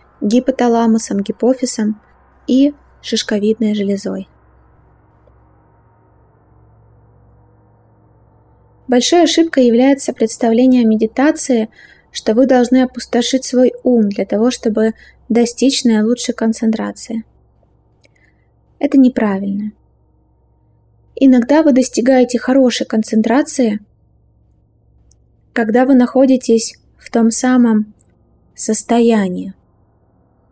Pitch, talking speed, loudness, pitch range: 230 Hz, 75 wpm, -13 LUFS, 185-255 Hz